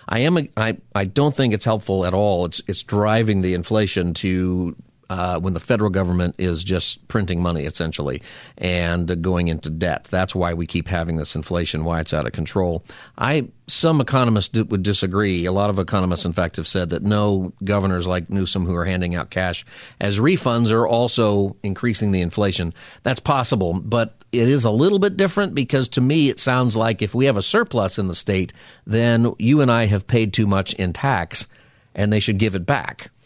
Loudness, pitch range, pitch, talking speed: -20 LUFS, 90-115 Hz, 100 Hz, 205 wpm